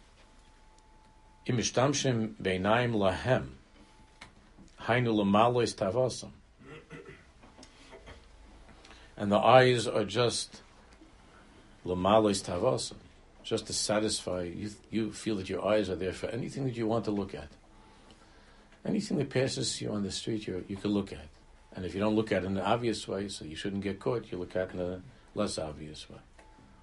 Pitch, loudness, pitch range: 105 Hz, -30 LUFS, 95-115 Hz